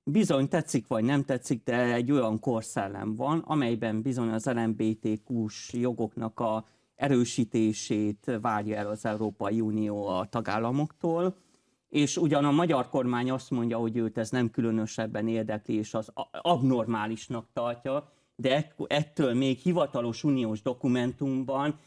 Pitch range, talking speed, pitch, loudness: 110-135 Hz, 130 wpm, 120 Hz, -29 LUFS